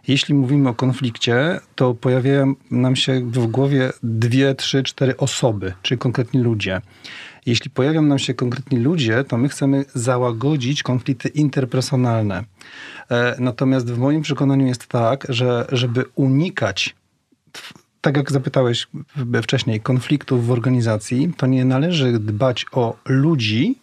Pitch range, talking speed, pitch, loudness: 120-140 Hz, 130 wpm, 130 Hz, -19 LUFS